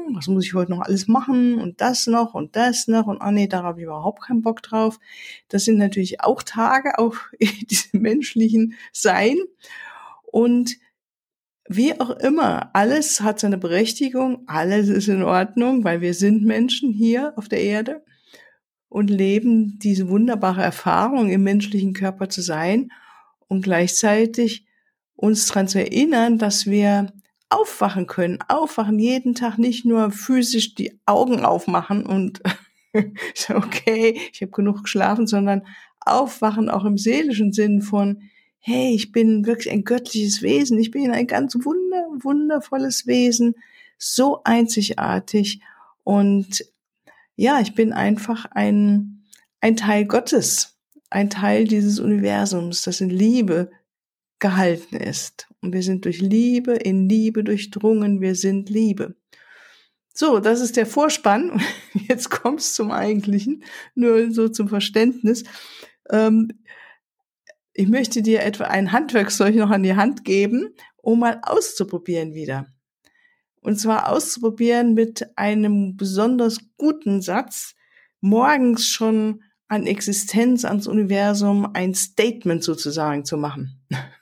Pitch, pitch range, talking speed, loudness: 220 Hz, 200-240 Hz, 135 wpm, -20 LUFS